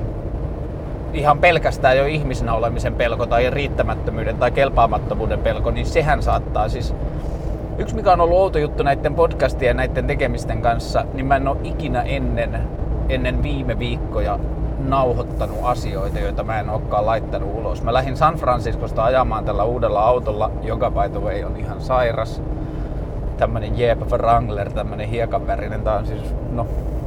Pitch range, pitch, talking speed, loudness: 110-140 Hz, 120 Hz, 150 wpm, -20 LUFS